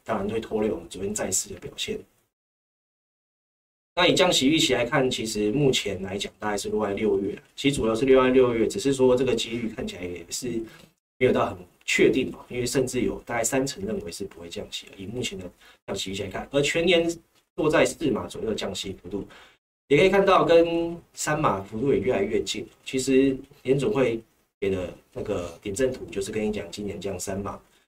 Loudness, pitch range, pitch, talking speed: -25 LUFS, 100-140 Hz, 120 Hz, 295 characters per minute